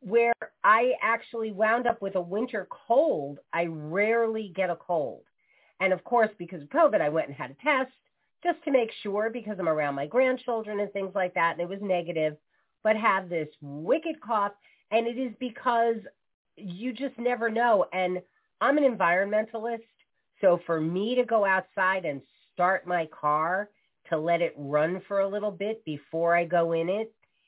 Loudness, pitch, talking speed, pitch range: -27 LUFS, 205 Hz, 180 wpm, 175-235 Hz